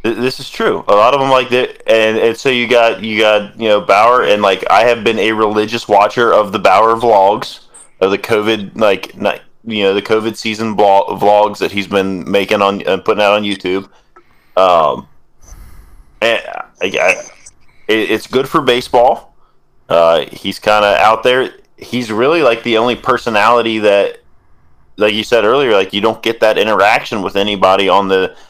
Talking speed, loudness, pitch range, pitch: 185 wpm, -12 LUFS, 100-115 Hz, 105 Hz